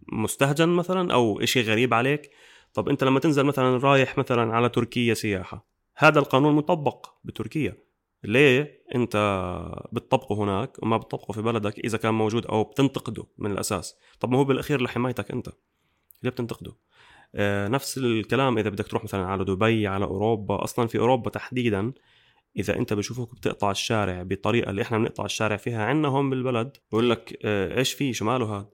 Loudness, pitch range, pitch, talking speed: -25 LUFS, 105-130 Hz, 115 Hz, 165 wpm